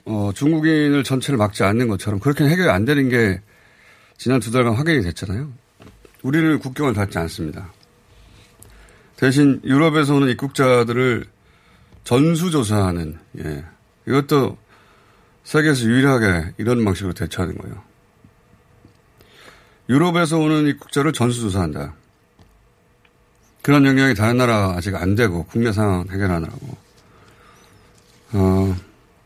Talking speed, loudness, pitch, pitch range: 275 characters per minute, -18 LUFS, 115 Hz, 95-140 Hz